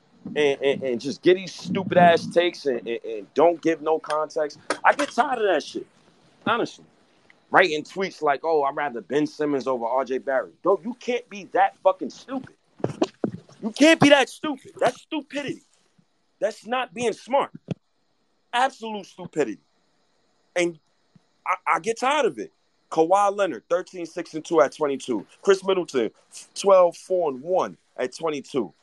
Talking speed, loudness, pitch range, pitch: 160 wpm, -23 LUFS, 155-240 Hz, 185 Hz